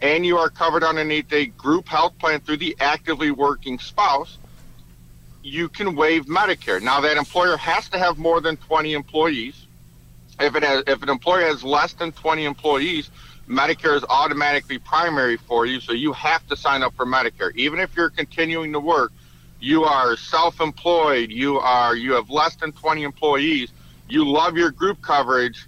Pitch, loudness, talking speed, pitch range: 150 Hz, -20 LUFS, 175 wpm, 125-165 Hz